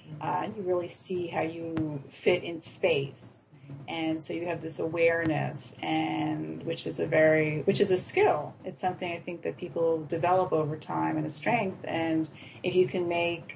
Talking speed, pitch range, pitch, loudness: 180 wpm, 150-175 Hz, 165 Hz, -29 LUFS